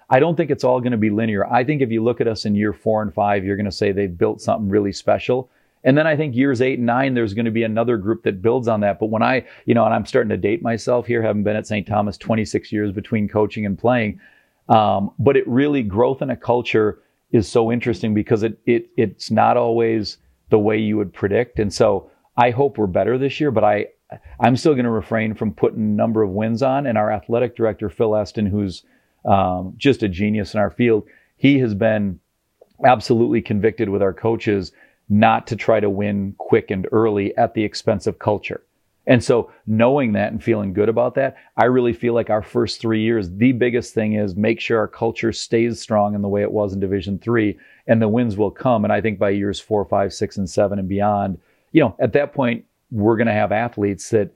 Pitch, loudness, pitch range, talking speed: 110 Hz, -19 LUFS, 105-120 Hz, 235 wpm